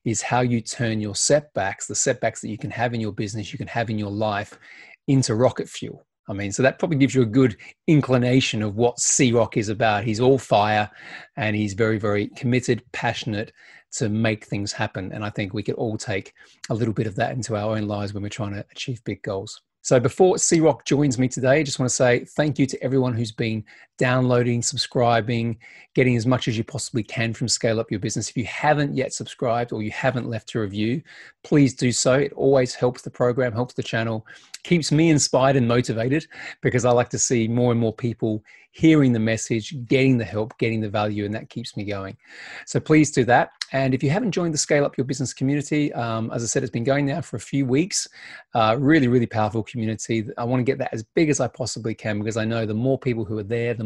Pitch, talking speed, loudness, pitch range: 120 Hz, 235 wpm, -22 LUFS, 110-135 Hz